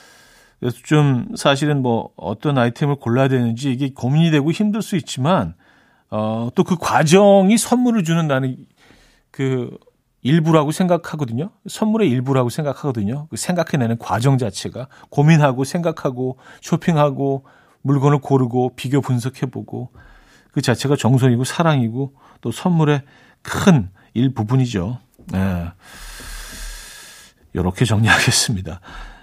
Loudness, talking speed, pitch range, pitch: -18 LUFS, 285 characters per minute, 120-155 Hz, 135 Hz